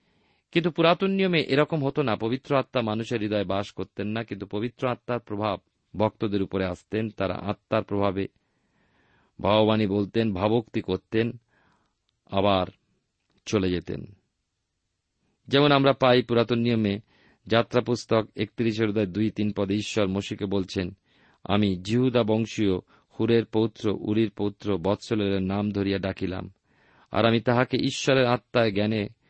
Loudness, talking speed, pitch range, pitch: -25 LUFS, 125 wpm, 100-120 Hz, 110 Hz